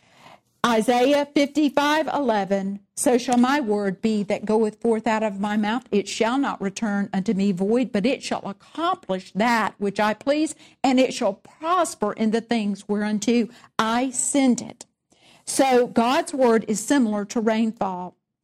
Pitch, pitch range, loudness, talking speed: 225 Hz, 205-255 Hz, -22 LUFS, 155 wpm